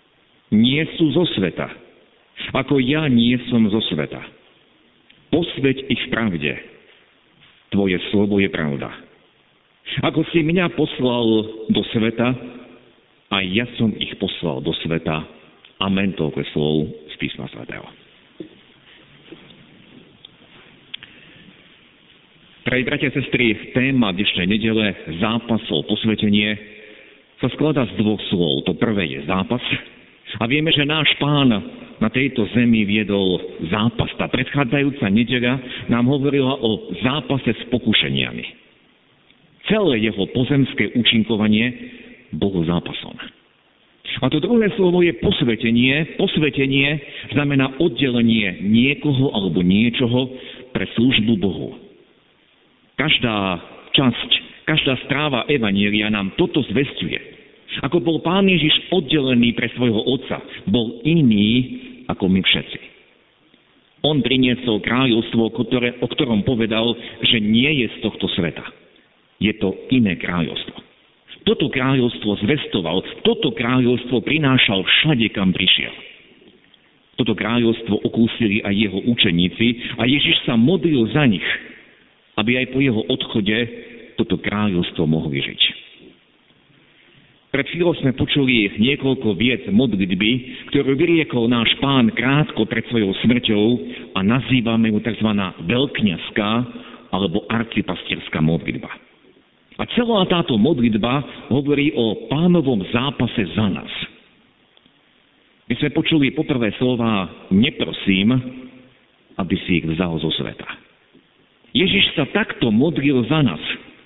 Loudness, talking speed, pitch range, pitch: -19 LUFS, 110 wpm, 105-135 Hz, 120 Hz